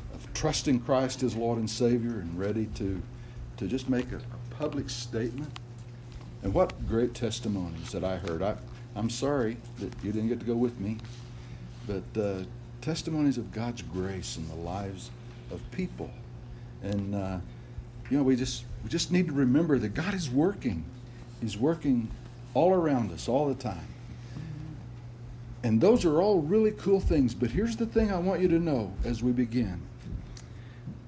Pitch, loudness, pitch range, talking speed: 120 Hz, -30 LUFS, 110-130 Hz, 170 wpm